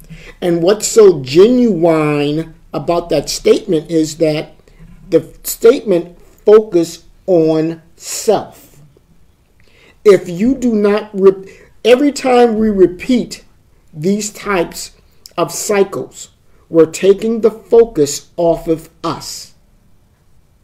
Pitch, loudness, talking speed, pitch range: 170 Hz, -13 LUFS, 100 wpm, 155-205 Hz